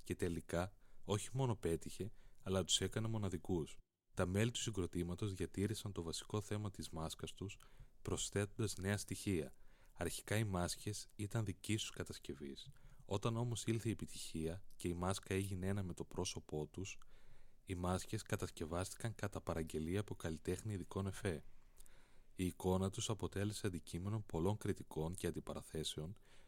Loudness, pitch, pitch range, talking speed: -43 LUFS, 95 Hz, 85-110 Hz, 140 wpm